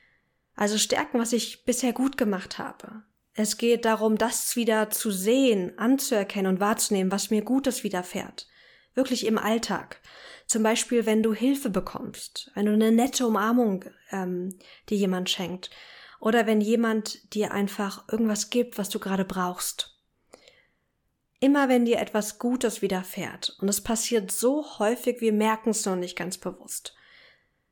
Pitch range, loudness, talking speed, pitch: 200-235 Hz, -26 LUFS, 150 wpm, 220 Hz